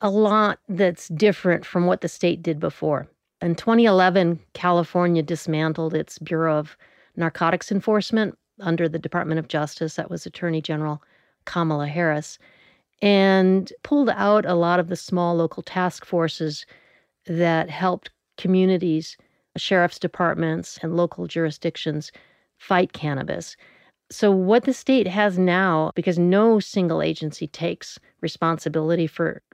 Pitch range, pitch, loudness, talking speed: 160-190 Hz, 175 Hz, -22 LUFS, 130 wpm